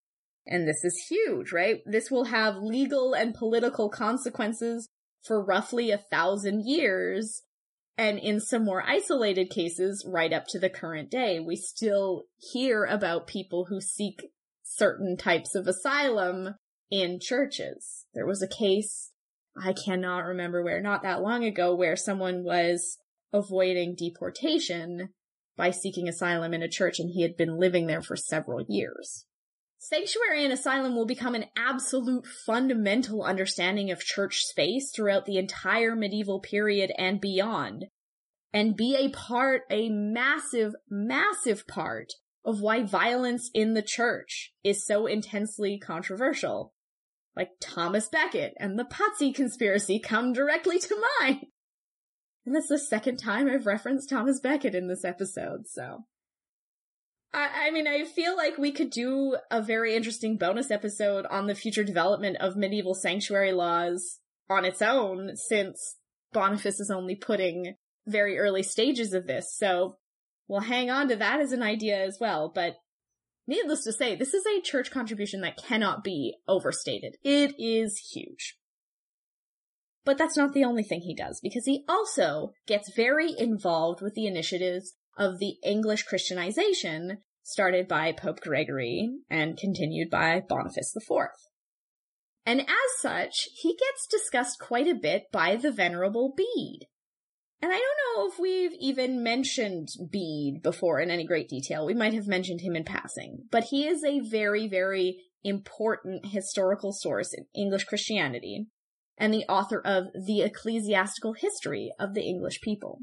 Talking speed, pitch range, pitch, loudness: 150 wpm, 190-255 Hz, 210 Hz, -28 LUFS